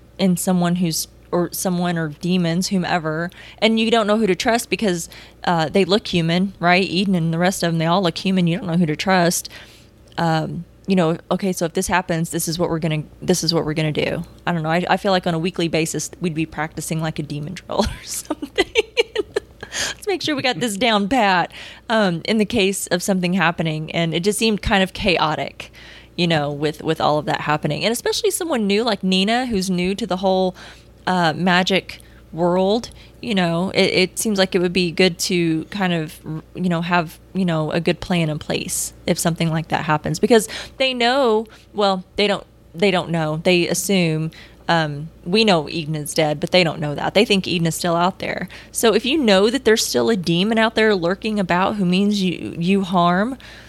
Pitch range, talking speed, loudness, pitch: 165-200 Hz, 220 wpm, -19 LUFS, 180 Hz